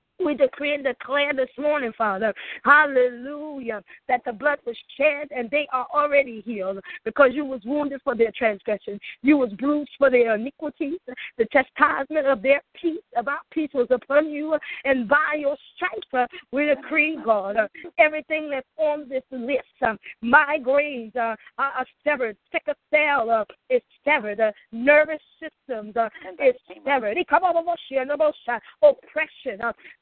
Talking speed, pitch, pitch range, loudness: 130 wpm, 280 Hz, 245-300 Hz, -23 LUFS